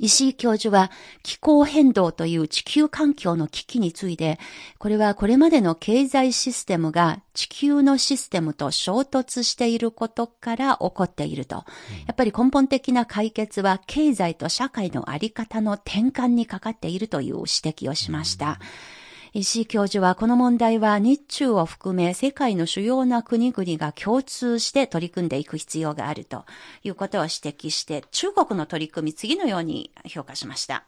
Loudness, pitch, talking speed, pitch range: -22 LUFS, 220 Hz, 330 characters per minute, 175-255 Hz